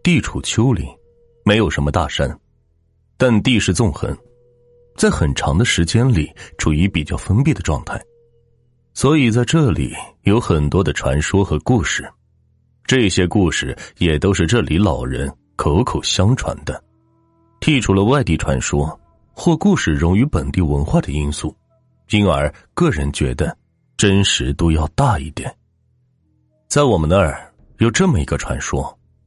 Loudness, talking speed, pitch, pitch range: -17 LUFS, 215 characters per minute, 100 Hz, 75-120 Hz